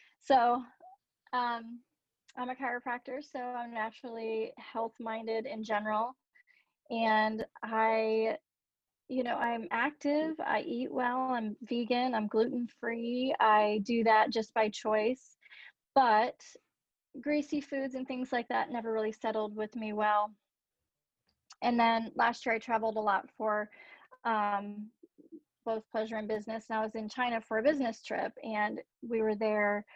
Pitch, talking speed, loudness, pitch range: 230 Hz, 145 wpm, -32 LUFS, 220-255 Hz